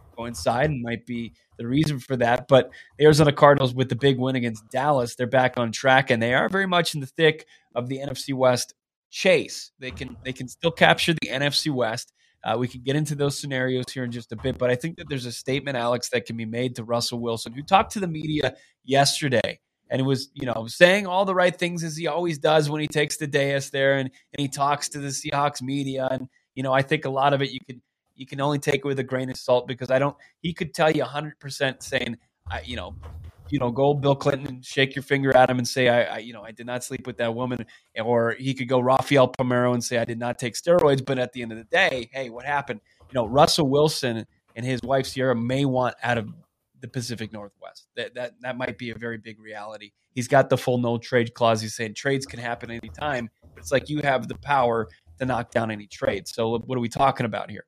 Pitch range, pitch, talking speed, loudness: 120-140 Hz, 130 Hz, 250 wpm, -24 LUFS